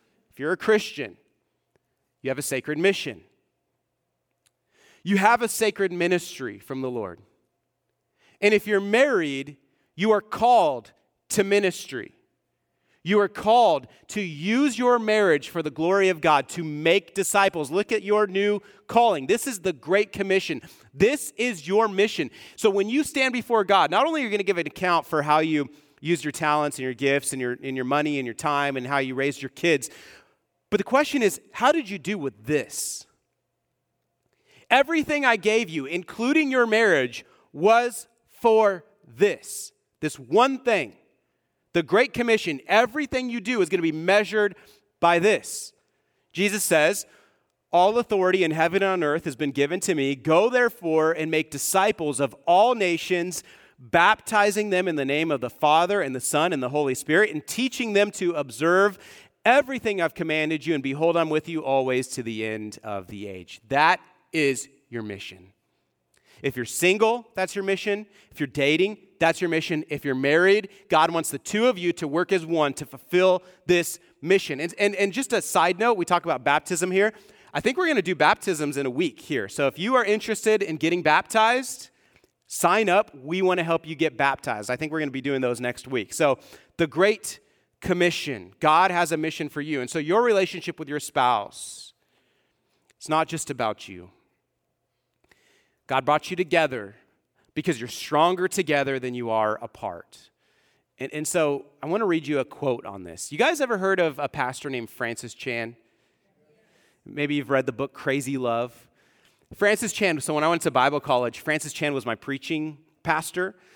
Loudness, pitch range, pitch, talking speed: -23 LUFS, 140-205 Hz, 165 Hz, 185 wpm